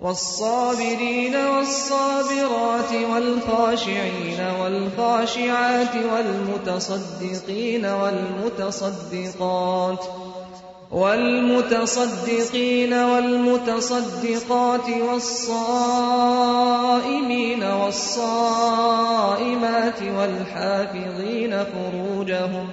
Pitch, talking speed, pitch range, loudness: 230 Hz, 30 wpm, 195-245 Hz, -22 LUFS